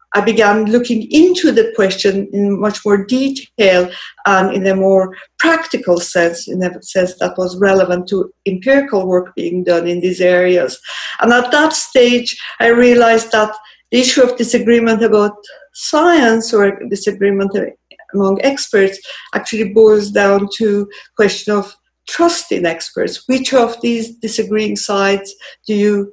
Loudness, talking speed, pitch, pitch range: -13 LUFS, 150 wpm, 210 Hz, 195-240 Hz